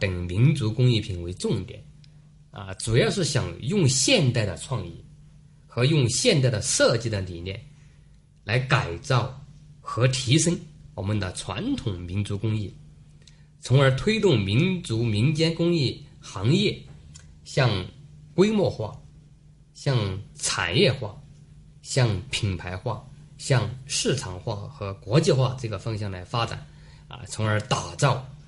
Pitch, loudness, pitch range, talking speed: 130 Hz, -24 LUFS, 110-150 Hz, 190 characters per minute